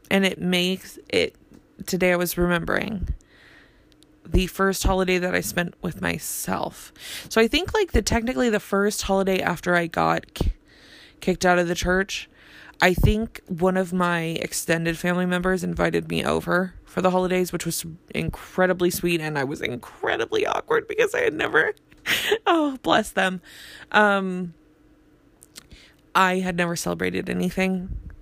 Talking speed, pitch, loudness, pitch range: 145 wpm, 185 Hz, -23 LUFS, 170-195 Hz